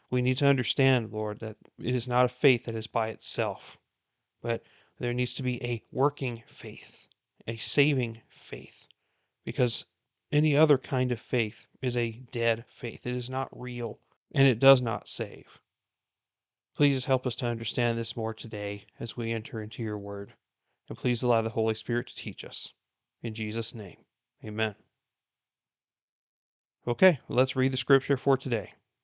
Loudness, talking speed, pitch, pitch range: -29 LUFS, 165 wpm, 120 Hz, 115-130 Hz